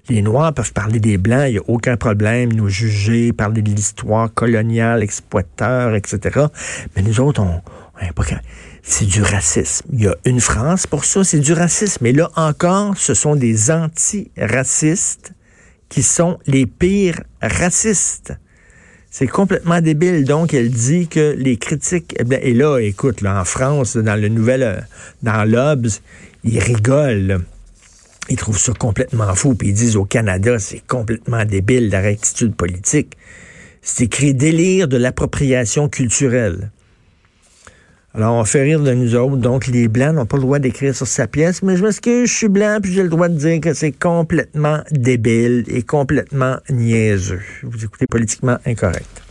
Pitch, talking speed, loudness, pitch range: 125 Hz, 165 wpm, -16 LUFS, 105-150 Hz